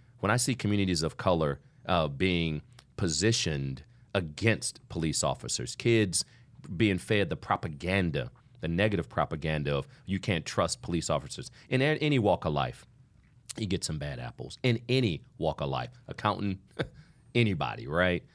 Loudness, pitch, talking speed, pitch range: -30 LUFS, 105 Hz, 145 wpm, 85-125 Hz